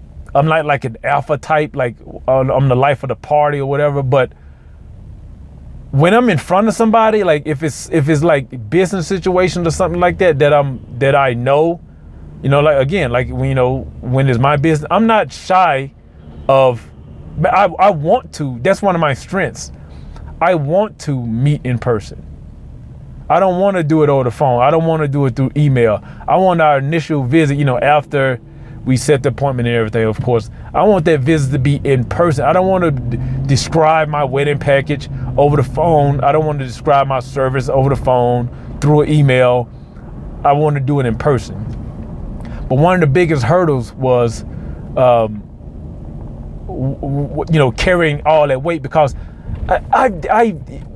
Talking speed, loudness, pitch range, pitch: 190 wpm, -14 LUFS, 125-155 Hz, 140 Hz